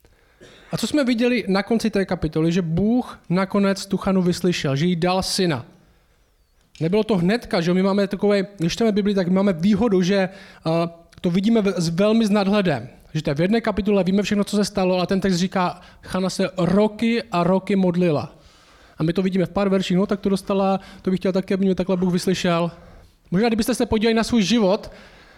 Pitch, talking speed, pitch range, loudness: 190 Hz, 200 wpm, 180-205 Hz, -21 LUFS